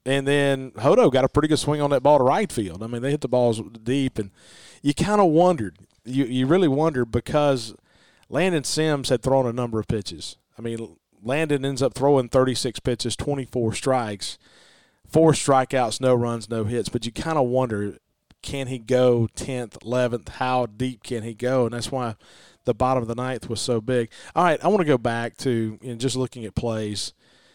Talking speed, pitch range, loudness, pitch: 205 wpm, 115-135 Hz, -23 LUFS, 125 Hz